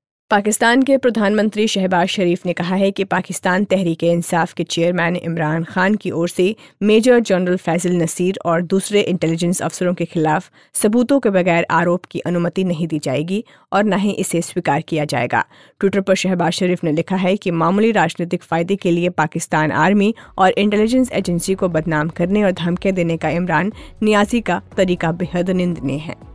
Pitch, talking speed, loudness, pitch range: 180 Hz, 175 wpm, -17 LUFS, 170-195 Hz